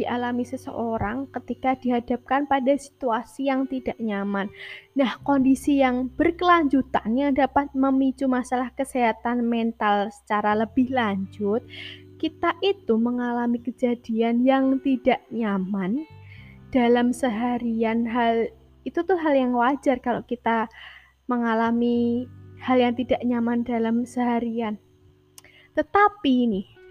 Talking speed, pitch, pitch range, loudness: 105 wpm, 245 Hz, 230-270 Hz, -24 LUFS